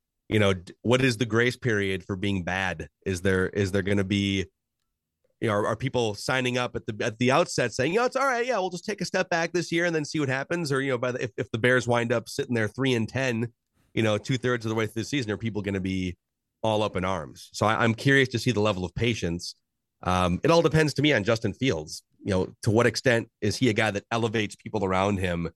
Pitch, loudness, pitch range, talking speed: 115 Hz, -26 LUFS, 100-130 Hz, 275 wpm